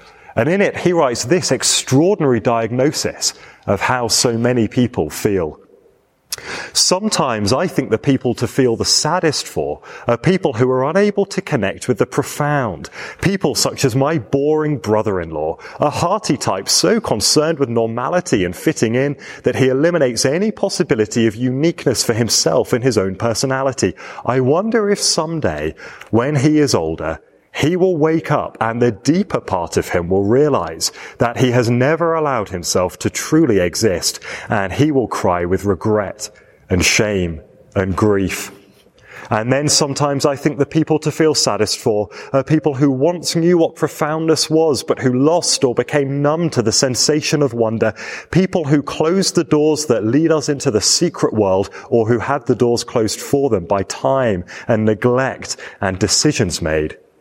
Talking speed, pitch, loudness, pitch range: 165 wpm, 135 Hz, -16 LUFS, 115-155 Hz